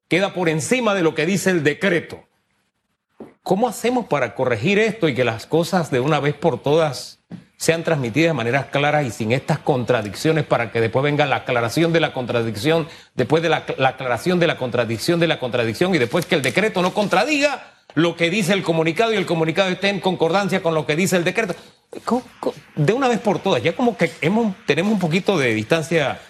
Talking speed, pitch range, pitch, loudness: 205 wpm, 140-190 Hz, 165 Hz, -19 LUFS